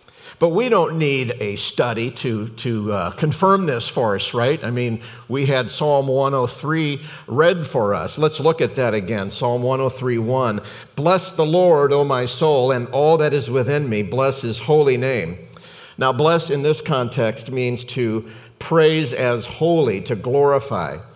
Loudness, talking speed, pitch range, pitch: -19 LUFS, 165 wpm, 120-150 Hz, 130 Hz